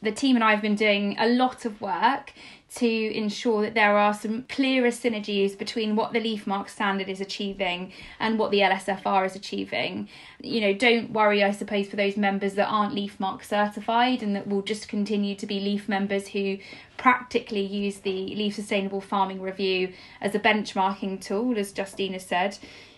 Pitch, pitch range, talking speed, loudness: 205 Hz, 195-220 Hz, 180 wpm, -25 LUFS